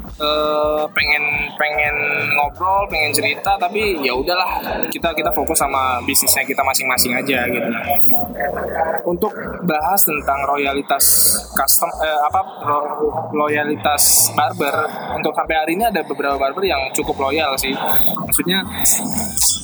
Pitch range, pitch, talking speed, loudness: 150-175 Hz, 150 Hz, 120 wpm, -16 LUFS